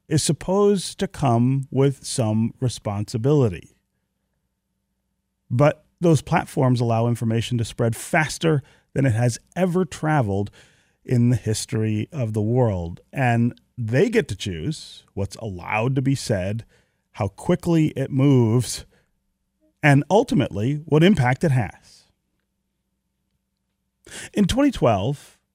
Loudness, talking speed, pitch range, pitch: -22 LUFS, 115 wpm, 115-155 Hz, 130 Hz